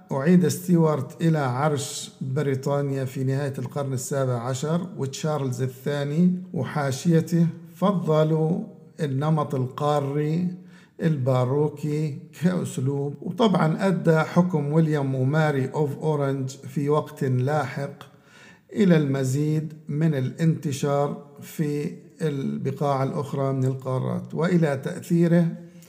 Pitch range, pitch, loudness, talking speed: 135-165 Hz, 150 Hz, -24 LUFS, 90 wpm